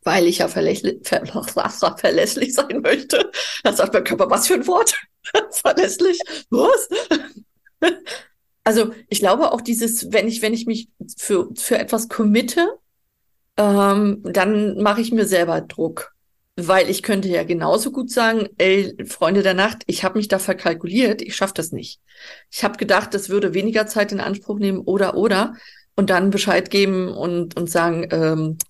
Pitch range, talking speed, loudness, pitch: 190-235 Hz, 160 wpm, -19 LUFS, 205 Hz